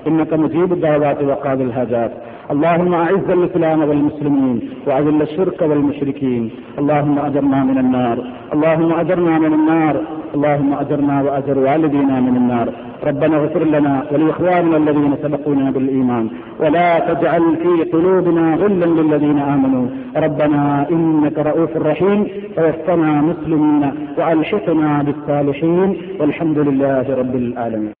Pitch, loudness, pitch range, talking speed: 150 Hz, -16 LUFS, 140-165 Hz, 110 wpm